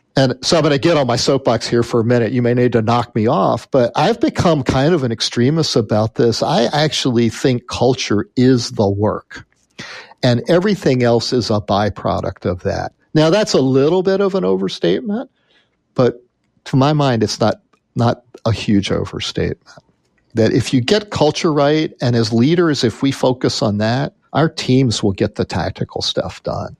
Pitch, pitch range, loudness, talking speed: 125 Hz, 115-150 Hz, -16 LUFS, 190 wpm